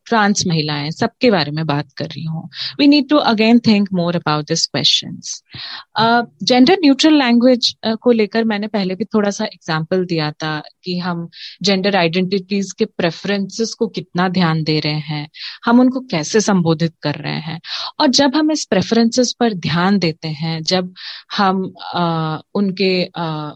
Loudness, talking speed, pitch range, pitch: -16 LUFS, 160 wpm, 165-225 Hz, 190 Hz